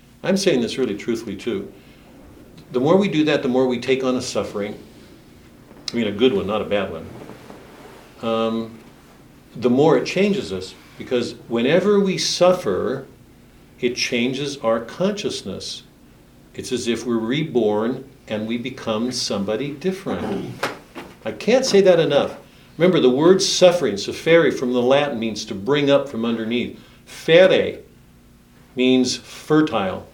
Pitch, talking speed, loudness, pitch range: 125 Hz, 145 wpm, -20 LUFS, 115-155 Hz